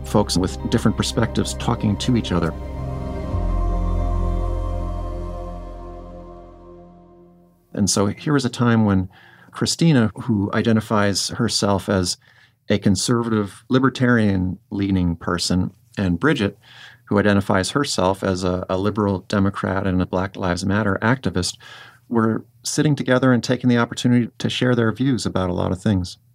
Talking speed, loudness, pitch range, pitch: 130 wpm, -21 LUFS, 85-115 Hz, 95 Hz